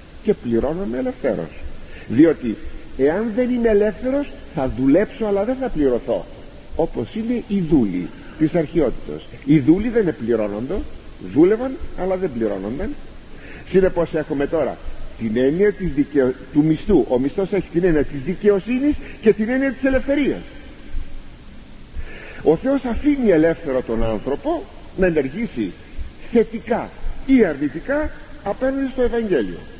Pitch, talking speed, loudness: 190 Hz, 125 wpm, -20 LUFS